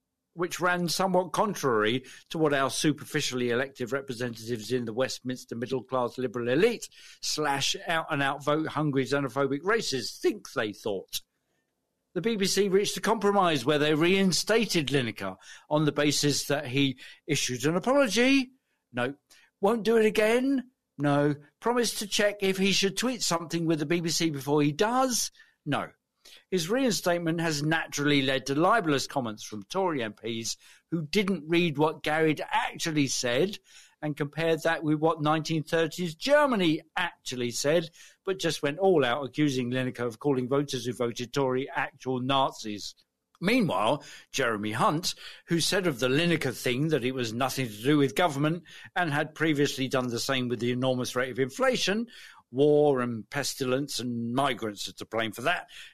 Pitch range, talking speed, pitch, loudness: 130-180 Hz, 160 wpm, 150 Hz, -27 LUFS